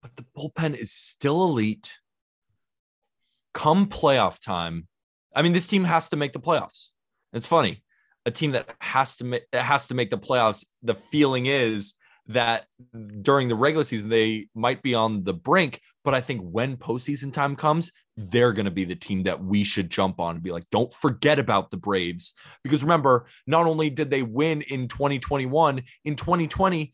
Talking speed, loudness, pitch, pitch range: 185 wpm, -24 LUFS, 130 Hz, 110-150 Hz